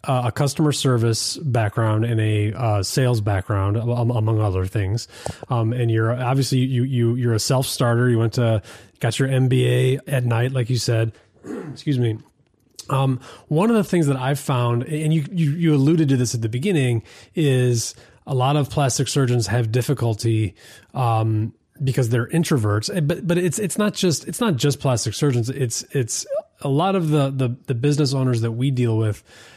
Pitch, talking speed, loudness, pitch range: 125 Hz, 190 wpm, -21 LUFS, 115-145 Hz